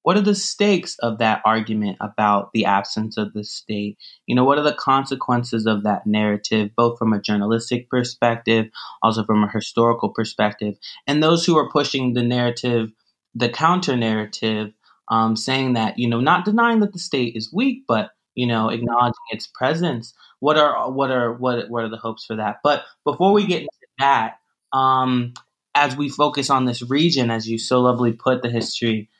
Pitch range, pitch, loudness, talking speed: 110-140 Hz, 120 Hz, -20 LUFS, 185 wpm